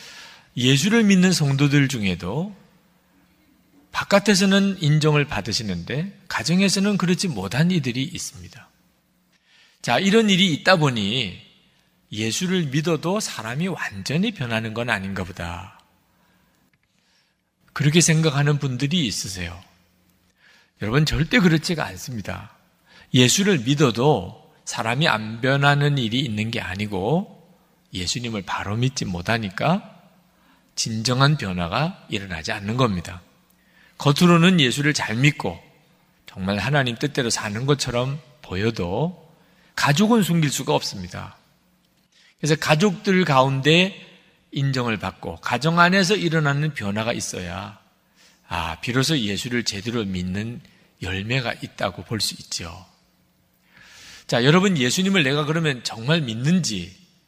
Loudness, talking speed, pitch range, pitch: -21 LUFS, 265 characters per minute, 110-170 Hz, 140 Hz